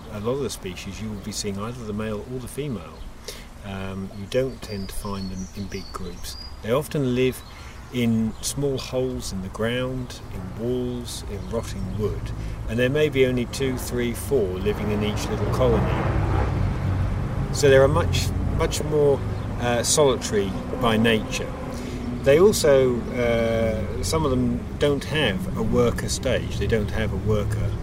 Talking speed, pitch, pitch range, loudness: 170 wpm, 110 Hz, 100-125 Hz, -24 LUFS